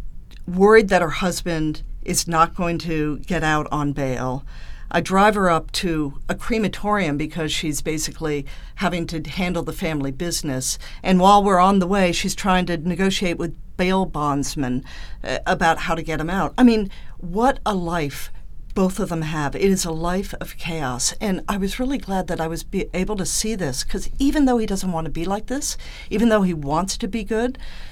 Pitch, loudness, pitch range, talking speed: 175 Hz, -21 LUFS, 155-195 Hz, 200 wpm